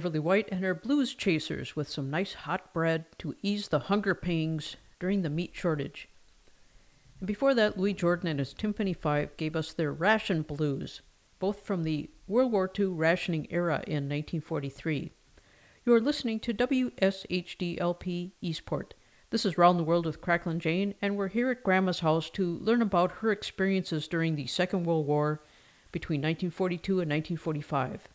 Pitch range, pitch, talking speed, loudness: 160-195 Hz, 175 Hz, 165 wpm, -30 LUFS